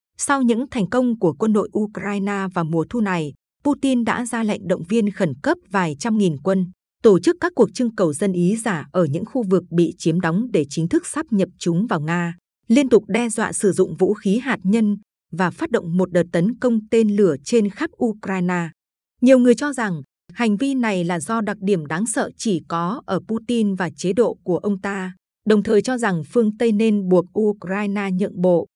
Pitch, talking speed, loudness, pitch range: 205 Hz, 215 wpm, -20 LUFS, 180-230 Hz